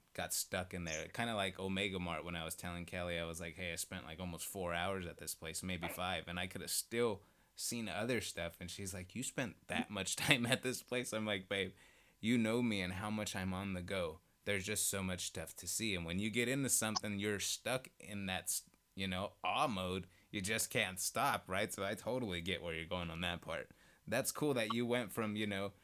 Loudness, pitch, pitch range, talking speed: -39 LUFS, 95 Hz, 90-105 Hz, 245 wpm